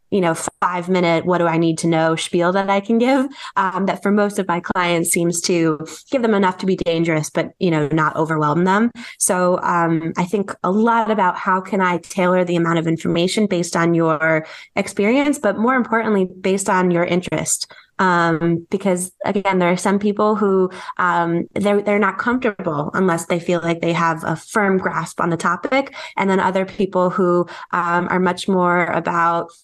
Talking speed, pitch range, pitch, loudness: 195 wpm, 170-200 Hz, 180 Hz, -18 LUFS